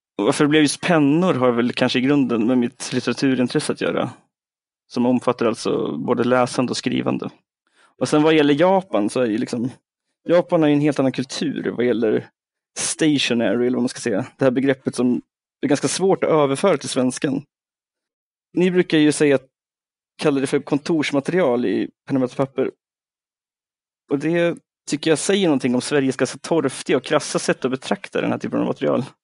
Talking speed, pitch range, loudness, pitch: 180 wpm, 125-155 Hz, -20 LUFS, 140 Hz